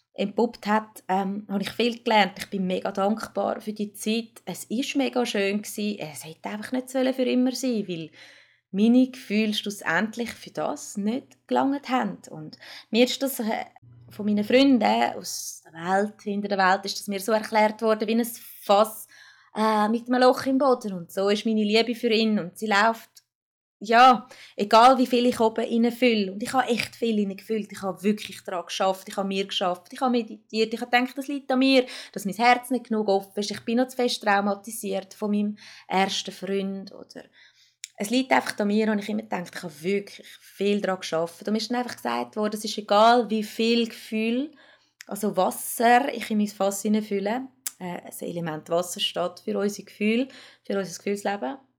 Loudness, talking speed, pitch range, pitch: -25 LUFS, 195 wpm, 195-240 Hz, 215 Hz